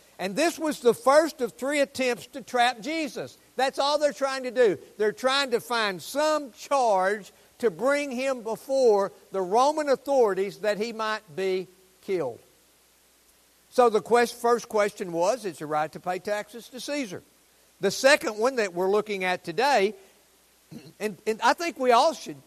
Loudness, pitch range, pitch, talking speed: -25 LUFS, 200-270 Hz, 235 Hz, 170 wpm